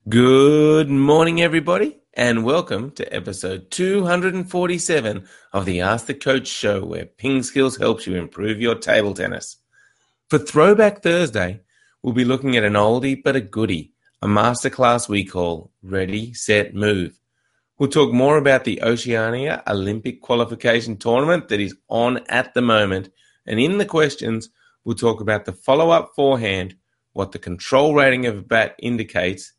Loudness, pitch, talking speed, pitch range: -19 LUFS, 120 Hz, 155 wpm, 105-140 Hz